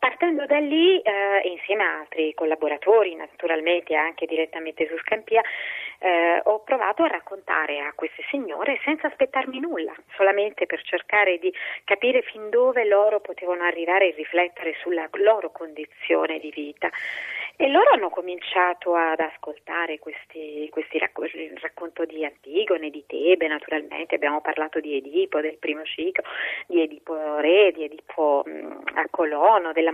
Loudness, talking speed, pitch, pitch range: -23 LUFS, 145 wpm, 170 Hz, 155-205 Hz